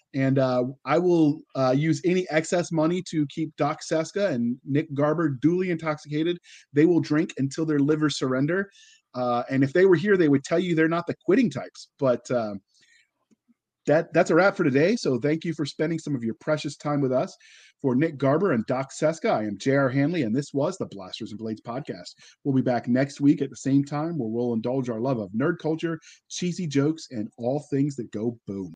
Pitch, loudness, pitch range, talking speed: 150 Hz, -25 LUFS, 135-165 Hz, 215 wpm